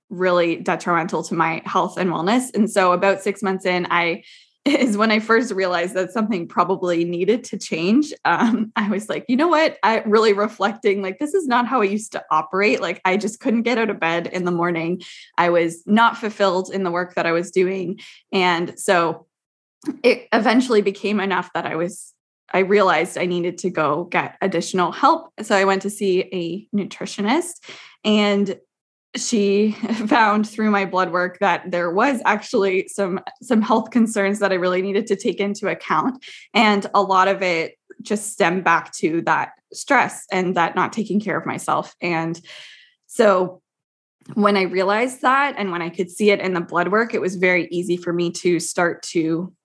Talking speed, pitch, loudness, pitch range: 190 wpm, 195 Hz, -20 LUFS, 175-215 Hz